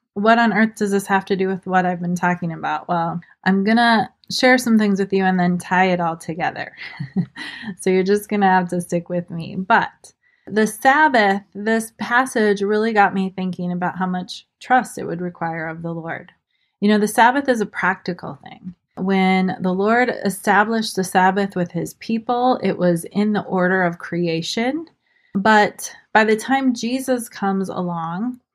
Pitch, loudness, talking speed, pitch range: 195 Hz, -19 LUFS, 185 wpm, 180-225 Hz